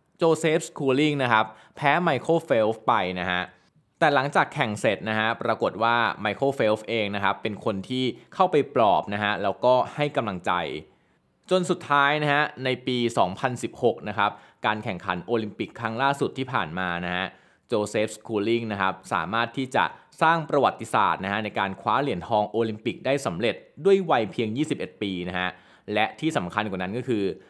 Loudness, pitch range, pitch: -25 LUFS, 100-140 Hz, 115 Hz